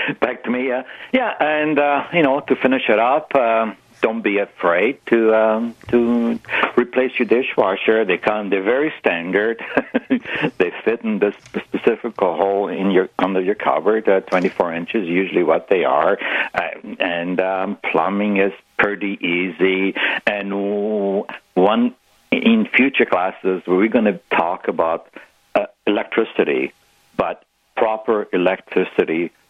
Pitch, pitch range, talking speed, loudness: 110 Hz, 100-140 Hz, 140 wpm, -18 LUFS